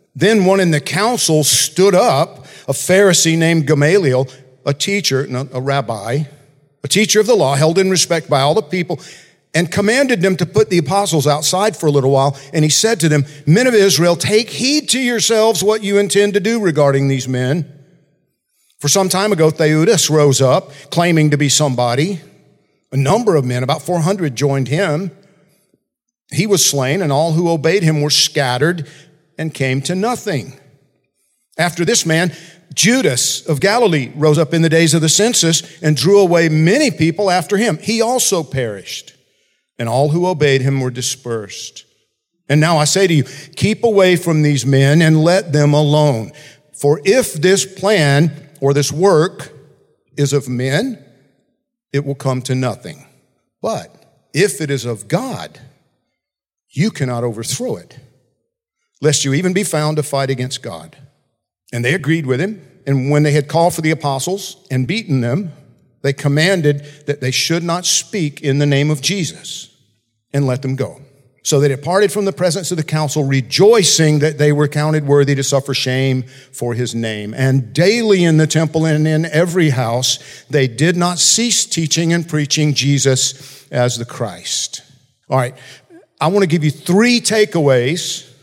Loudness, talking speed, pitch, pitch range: -14 LUFS, 175 wpm, 150 Hz, 135-180 Hz